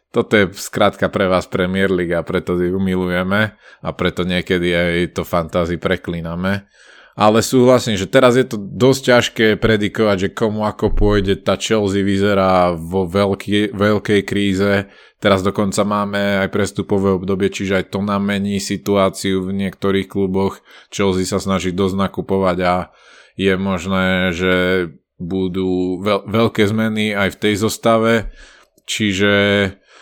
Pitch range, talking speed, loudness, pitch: 95-105 Hz, 145 wpm, -17 LUFS, 100 Hz